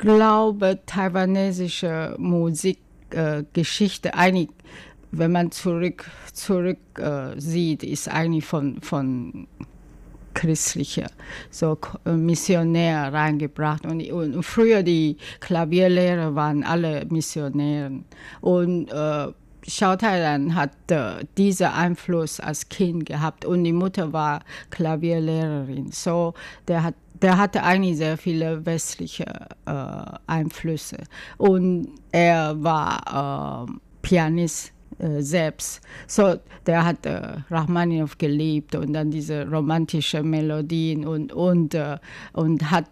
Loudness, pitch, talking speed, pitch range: -23 LUFS, 165 Hz, 105 wpm, 150-175 Hz